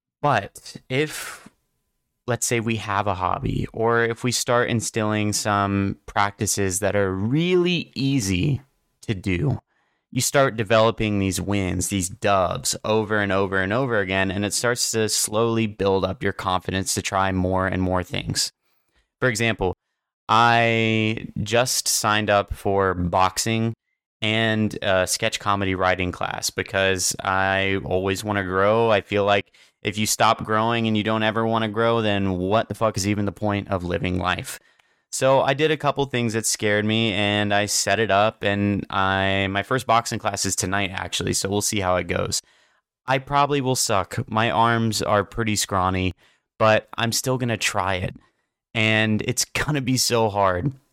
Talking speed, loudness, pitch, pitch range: 170 wpm, -22 LUFS, 105 Hz, 95-115 Hz